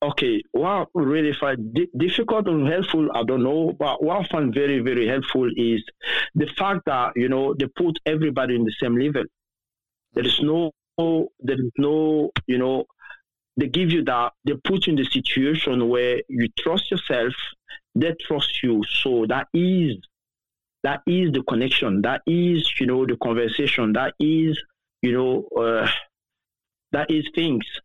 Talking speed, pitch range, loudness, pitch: 165 wpm, 125-165 Hz, -22 LUFS, 145 Hz